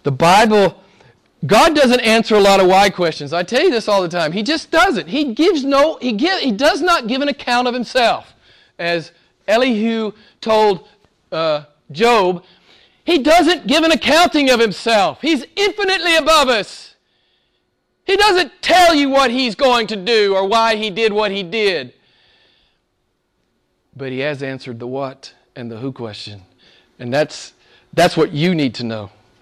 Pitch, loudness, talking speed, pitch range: 220 Hz, -15 LUFS, 170 wpm, 170-285 Hz